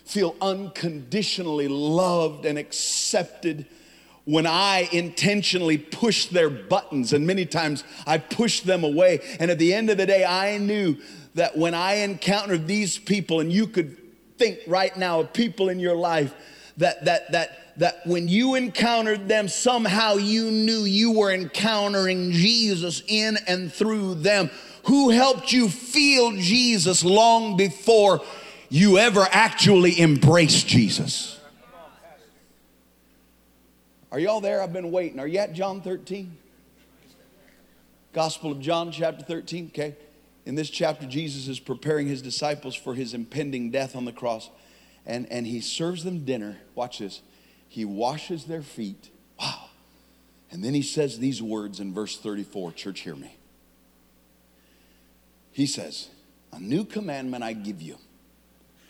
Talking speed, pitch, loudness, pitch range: 145 wpm, 170 Hz, -22 LUFS, 140-200 Hz